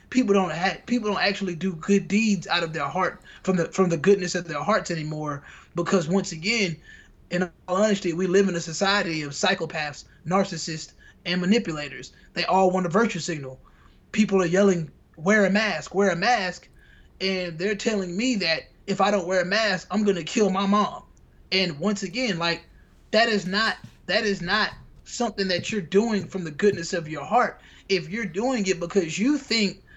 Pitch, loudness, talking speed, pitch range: 190 Hz, -24 LUFS, 195 wpm, 175-205 Hz